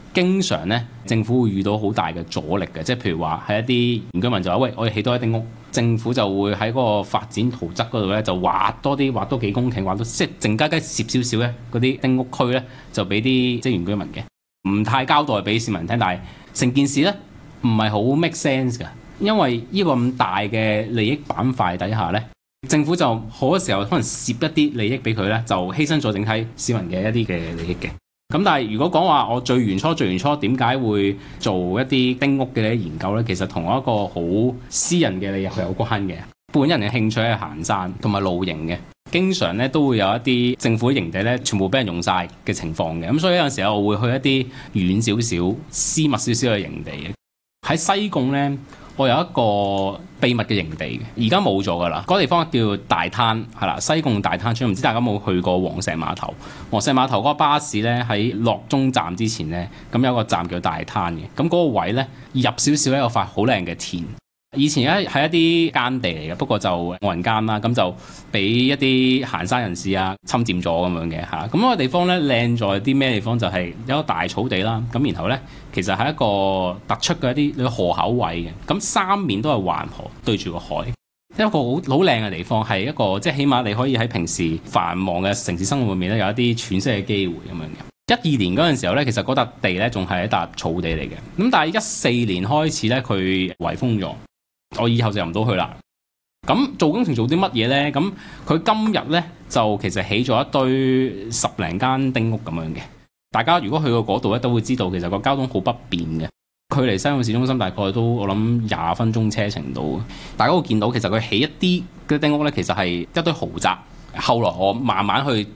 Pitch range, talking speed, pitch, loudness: 95-130 Hz, 315 characters per minute, 115 Hz, -20 LUFS